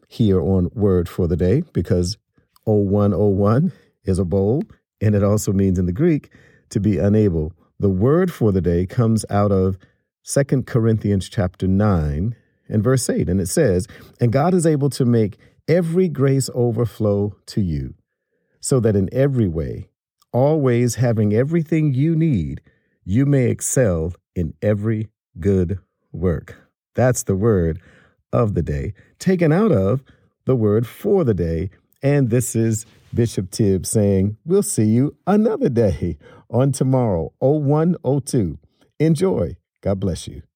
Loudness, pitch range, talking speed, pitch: -19 LUFS, 95-130 Hz, 145 wpm, 110 Hz